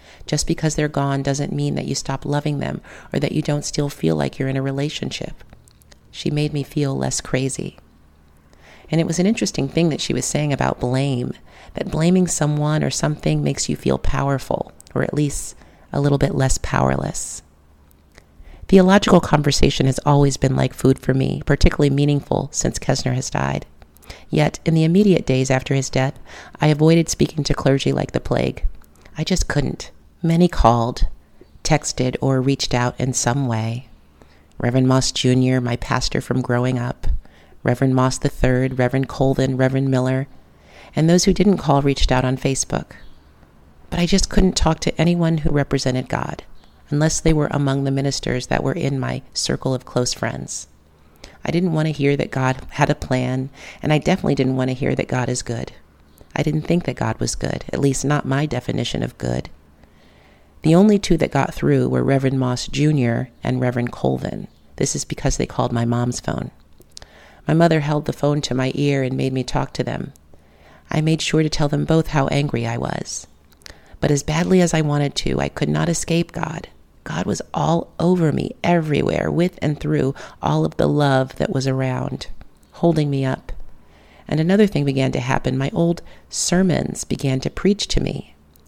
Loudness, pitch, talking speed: -20 LUFS, 130 Hz, 185 wpm